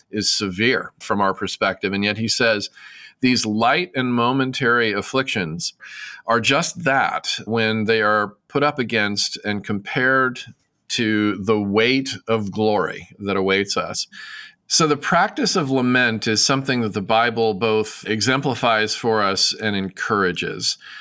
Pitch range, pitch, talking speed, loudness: 105-130 Hz, 110 Hz, 140 wpm, -20 LUFS